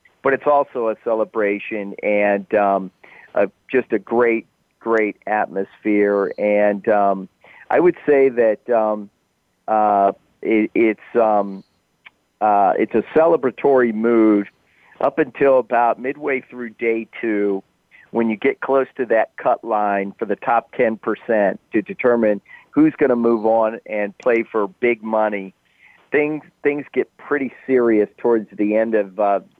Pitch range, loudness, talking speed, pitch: 105-120 Hz, -19 LUFS, 145 wpm, 110 Hz